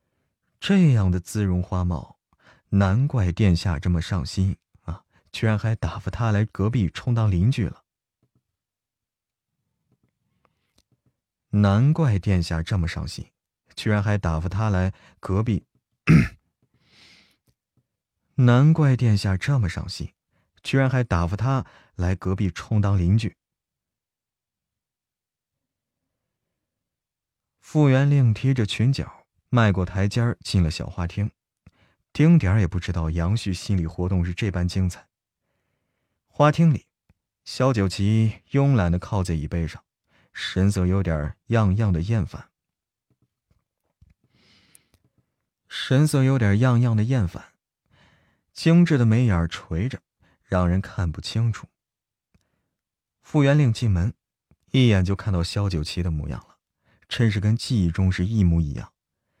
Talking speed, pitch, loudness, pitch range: 180 characters per minute, 100 Hz, -22 LUFS, 90-120 Hz